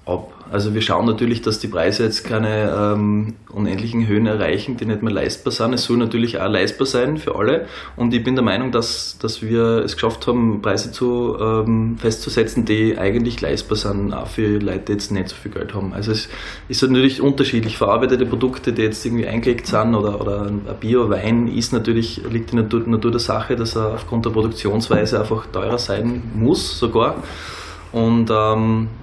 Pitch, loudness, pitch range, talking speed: 110 Hz, -19 LUFS, 105-120 Hz, 190 wpm